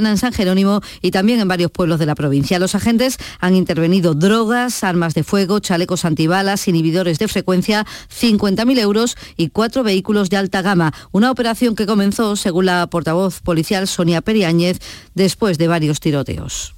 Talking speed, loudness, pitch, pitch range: 165 wpm, -16 LUFS, 190 Hz, 170-215 Hz